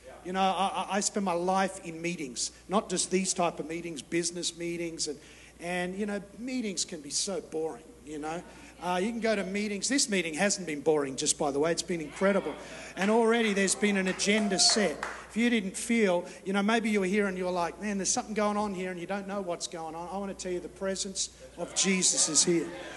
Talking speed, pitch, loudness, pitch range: 240 wpm, 185 Hz, -29 LUFS, 170-205 Hz